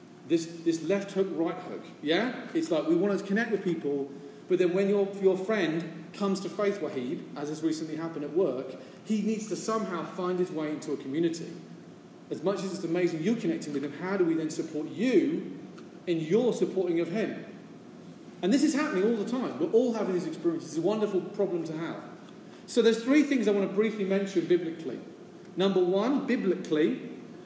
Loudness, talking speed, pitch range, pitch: -29 LUFS, 200 wpm, 165-205 Hz, 185 Hz